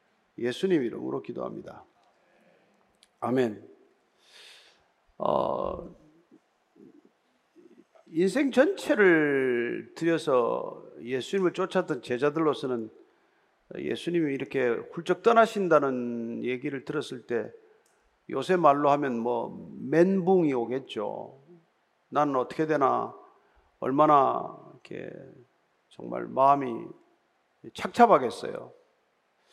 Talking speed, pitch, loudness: 190 characters per minute, 165 Hz, -27 LUFS